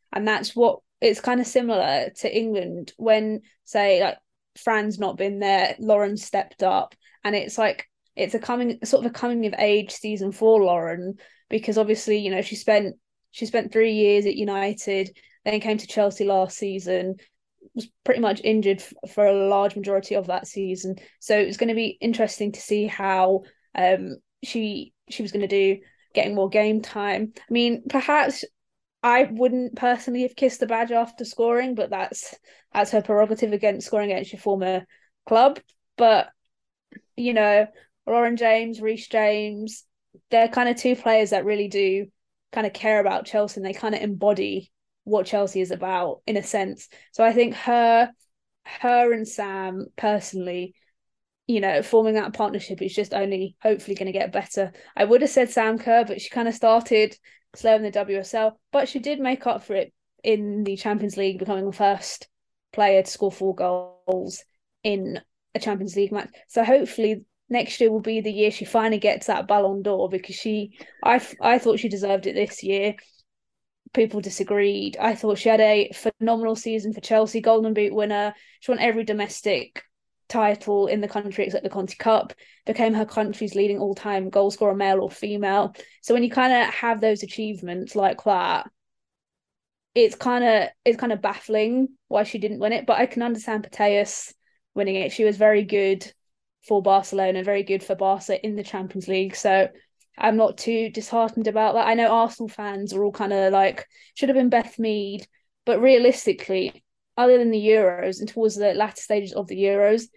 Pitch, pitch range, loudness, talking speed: 215 Hz, 200-230 Hz, -22 LUFS, 185 wpm